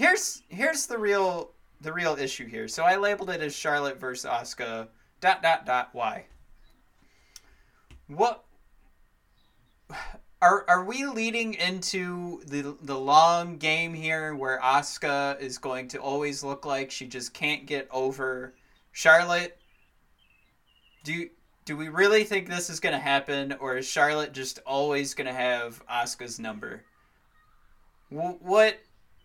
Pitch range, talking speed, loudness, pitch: 130-175 Hz, 135 wpm, -27 LUFS, 150 Hz